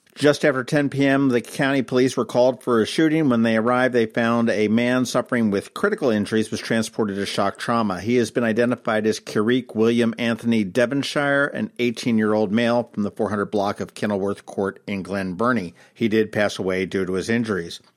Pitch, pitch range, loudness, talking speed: 115 Hz, 105-125 Hz, -21 LUFS, 195 wpm